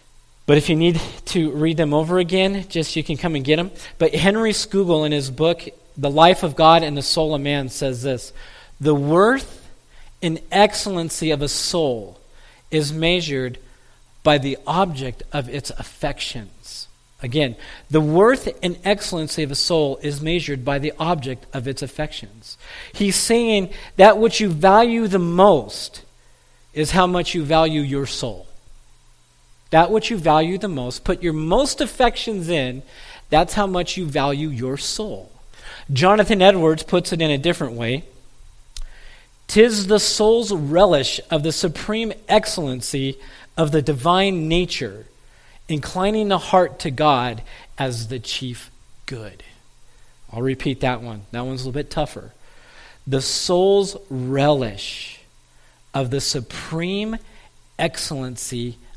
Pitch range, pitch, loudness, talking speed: 135-180 Hz, 155 Hz, -19 LUFS, 145 wpm